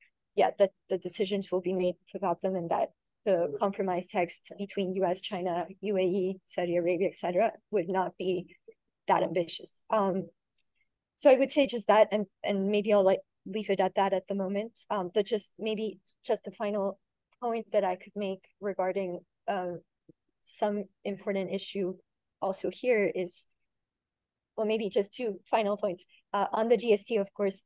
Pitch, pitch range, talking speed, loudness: 195 Hz, 185-210 Hz, 170 wpm, -30 LUFS